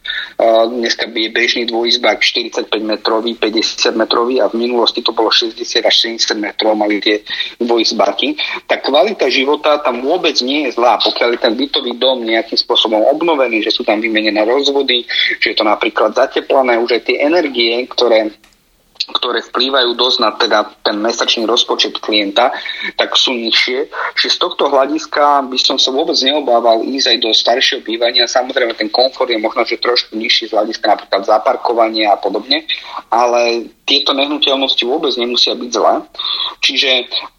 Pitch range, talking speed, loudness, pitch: 115-140 Hz, 160 wpm, -13 LUFS, 120 Hz